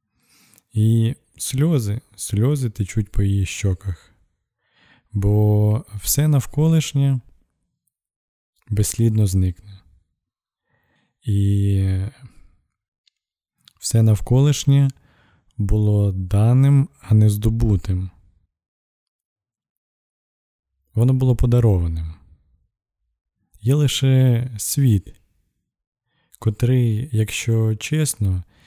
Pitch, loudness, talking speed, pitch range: 105 Hz, -19 LUFS, 60 wpm, 95-125 Hz